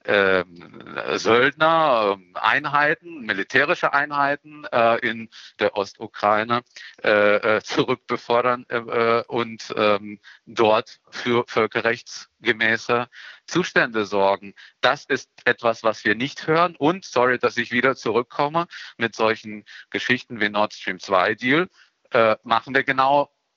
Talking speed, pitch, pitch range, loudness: 95 wpm, 120 Hz, 110-135 Hz, -21 LUFS